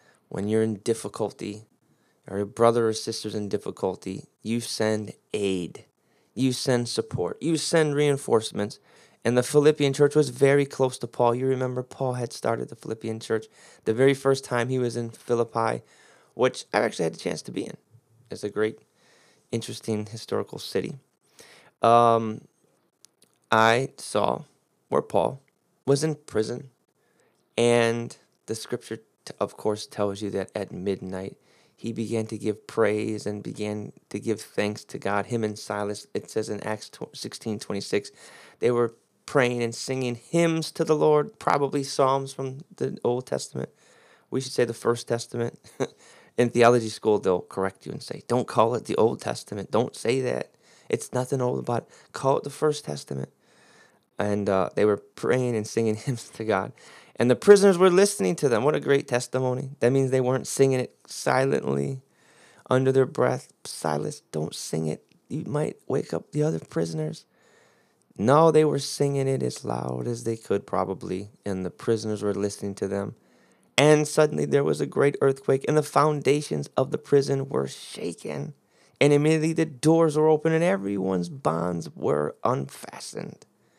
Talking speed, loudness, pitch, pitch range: 165 wpm, -25 LUFS, 115 Hz, 105-135 Hz